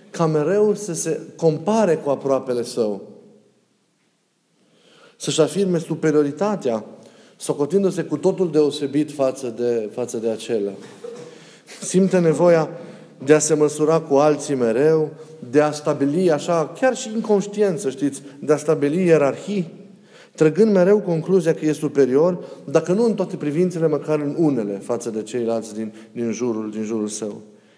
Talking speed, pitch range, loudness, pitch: 140 wpm, 140-180 Hz, -20 LUFS, 155 Hz